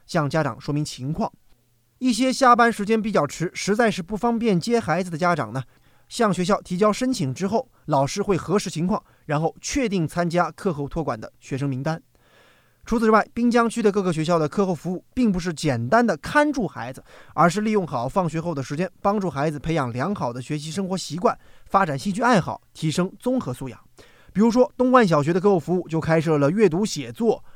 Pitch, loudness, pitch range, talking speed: 180 Hz, -22 LUFS, 150-215 Hz, 315 characters per minute